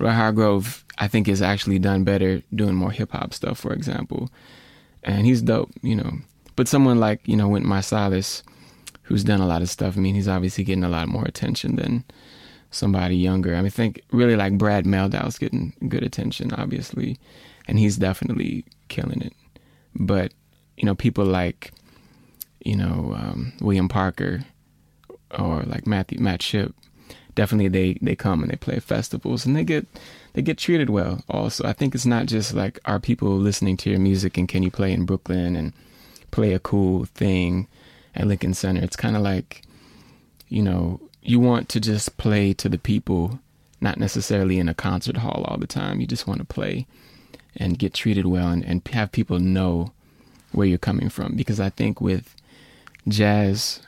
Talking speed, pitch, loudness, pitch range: 185 wpm, 100 Hz, -23 LUFS, 95-110 Hz